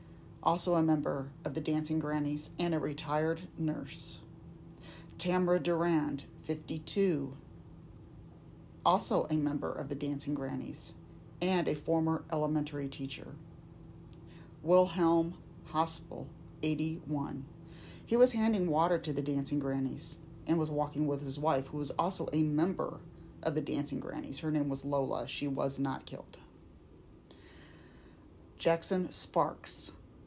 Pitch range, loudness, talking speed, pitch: 140-165 Hz, -33 LUFS, 125 wpm, 155 Hz